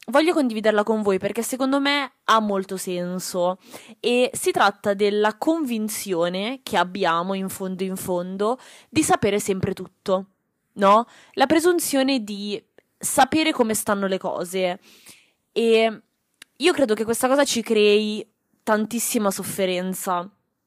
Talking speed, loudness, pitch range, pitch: 130 wpm, -22 LUFS, 190-250 Hz, 215 Hz